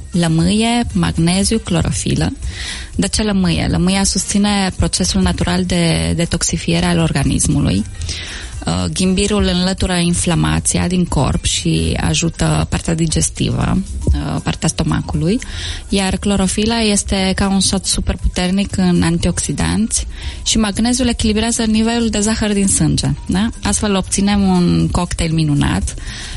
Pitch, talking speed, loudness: 170 Hz, 110 wpm, -16 LUFS